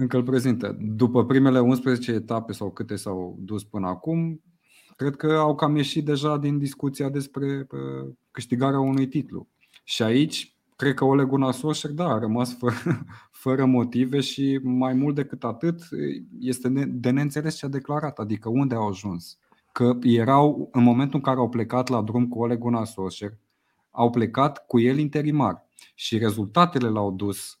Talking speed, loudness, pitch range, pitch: 160 wpm, -24 LUFS, 115-140 Hz, 130 Hz